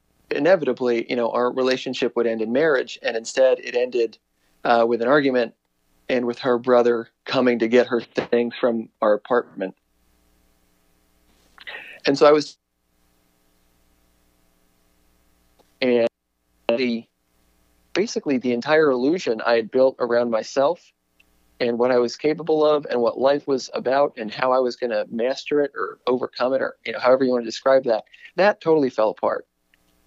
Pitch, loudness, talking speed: 115 Hz, -21 LUFS, 160 wpm